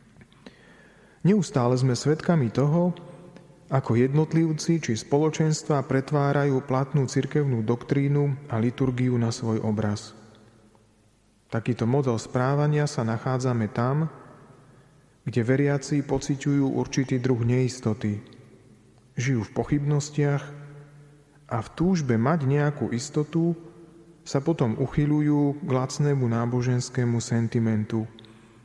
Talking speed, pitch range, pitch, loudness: 95 wpm, 120-145 Hz, 135 Hz, -25 LUFS